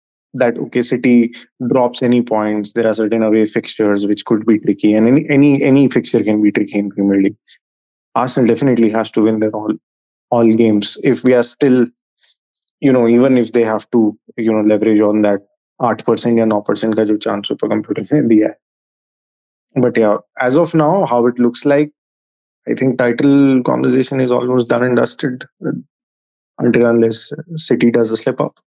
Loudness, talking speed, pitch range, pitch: -14 LUFS, 180 wpm, 105-125 Hz, 115 Hz